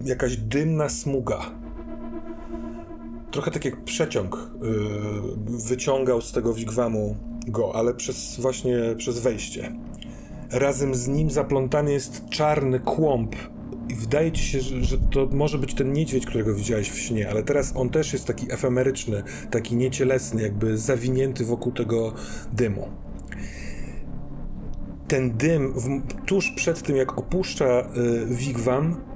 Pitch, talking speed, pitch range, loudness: 125 Hz, 130 wpm, 115-135 Hz, -25 LUFS